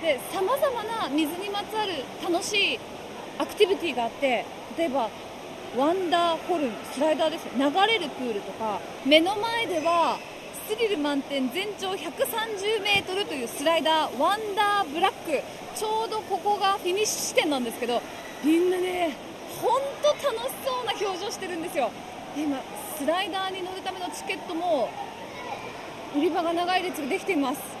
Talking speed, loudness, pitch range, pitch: 330 characters per minute, -26 LUFS, 310-405 Hz, 355 Hz